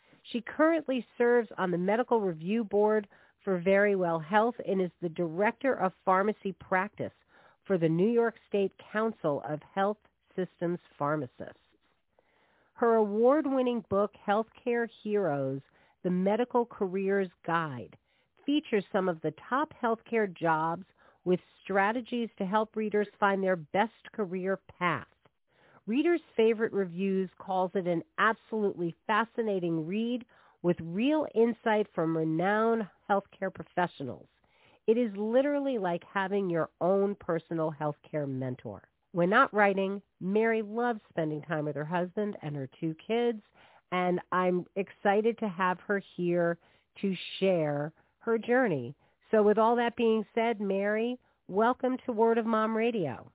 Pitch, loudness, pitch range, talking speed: 200 Hz, -30 LUFS, 175-225 Hz, 135 wpm